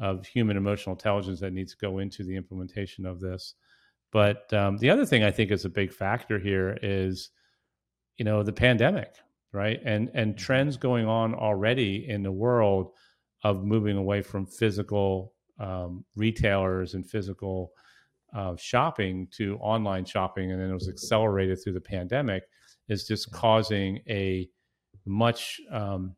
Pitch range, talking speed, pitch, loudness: 95-110 Hz, 155 wpm, 100 Hz, -28 LUFS